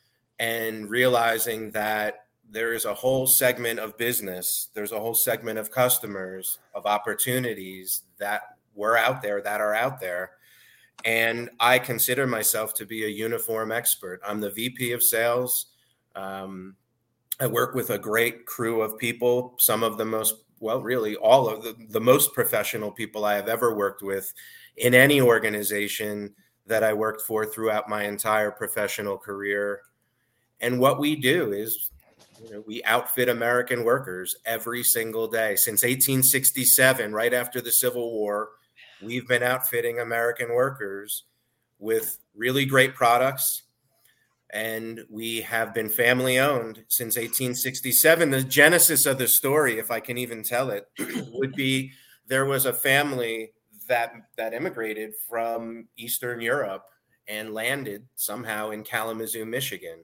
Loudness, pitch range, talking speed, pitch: -24 LUFS, 110-125 Hz, 145 wpm, 115 Hz